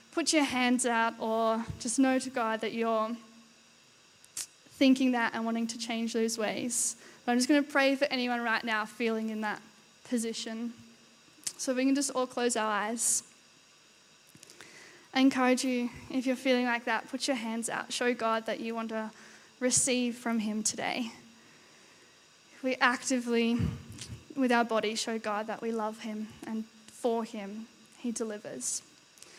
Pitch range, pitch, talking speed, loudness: 225-255 Hz, 235 Hz, 165 wpm, -30 LUFS